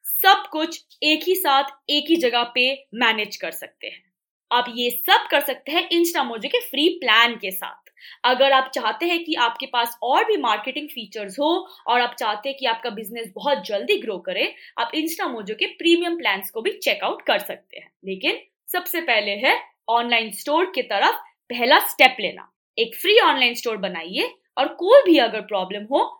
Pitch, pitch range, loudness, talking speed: 275 Hz, 235-345 Hz, -20 LUFS, 185 wpm